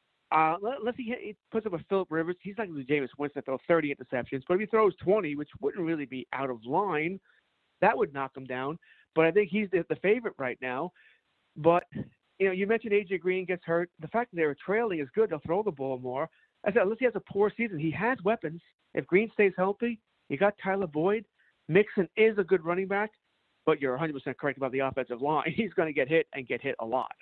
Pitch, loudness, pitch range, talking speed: 175 Hz, -29 LUFS, 145-210 Hz, 235 wpm